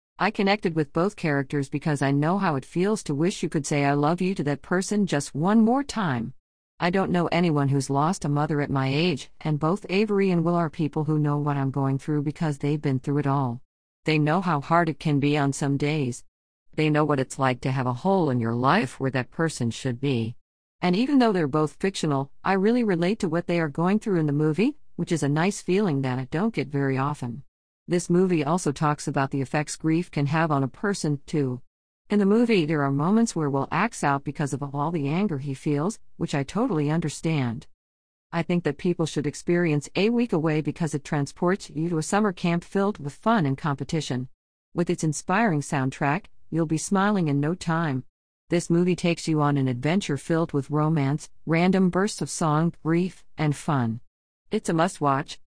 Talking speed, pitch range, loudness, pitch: 215 wpm, 140-175 Hz, -25 LUFS, 155 Hz